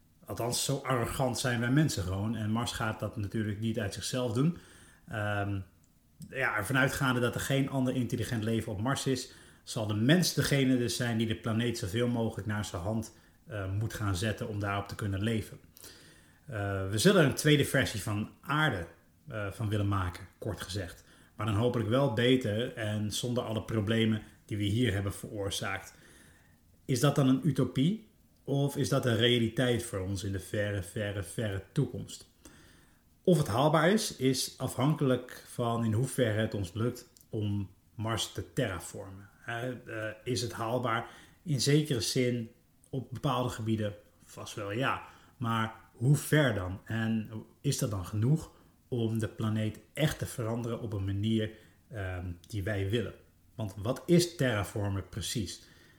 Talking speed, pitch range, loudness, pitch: 160 wpm, 100-125 Hz, -31 LUFS, 115 Hz